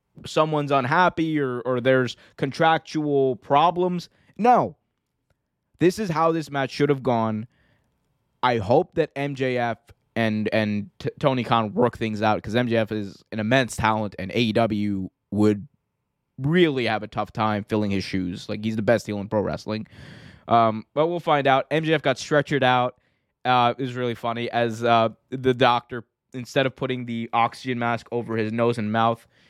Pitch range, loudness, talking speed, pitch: 110-140 Hz, -23 LUFS, 165 wpm, 120 Hz